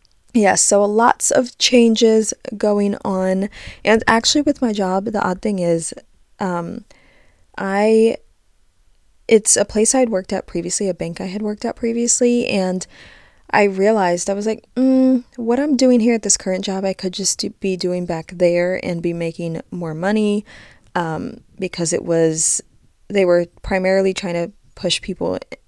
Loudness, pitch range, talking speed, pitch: -18 LUFS, 185-225 Hz, 165 wpm, 200 Hz